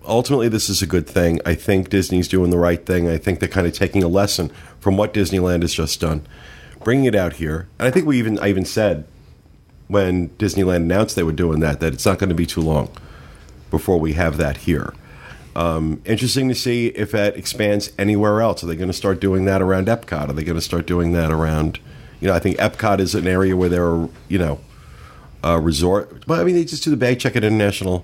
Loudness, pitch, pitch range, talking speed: -19 LUFS, 90 Hz, 85-105 Hz, 230 wpm